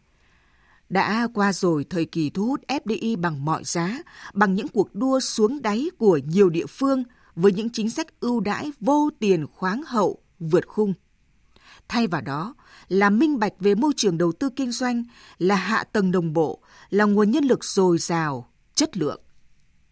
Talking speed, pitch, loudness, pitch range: 180 wpm, 200 Hz, -23 LUFS, 170-235 Hz